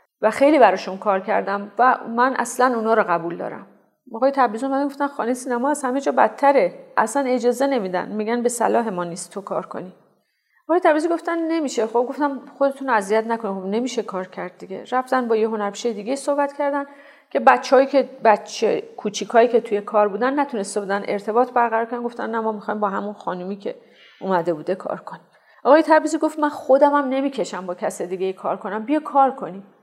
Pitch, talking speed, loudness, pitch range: 240 Hz, 190 wpm, -20 LUFS, 205-275 Hz